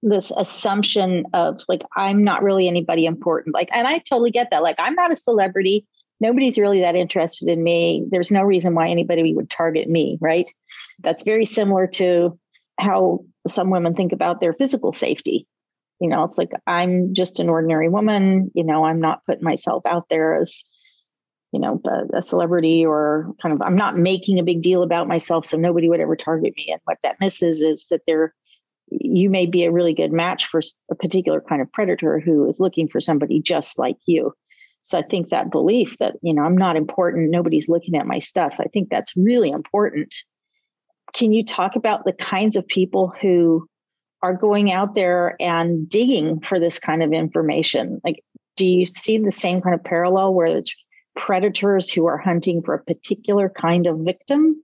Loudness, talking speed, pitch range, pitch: -19 LUFS, 195 wpm, 165-200 Hz, 180 Hz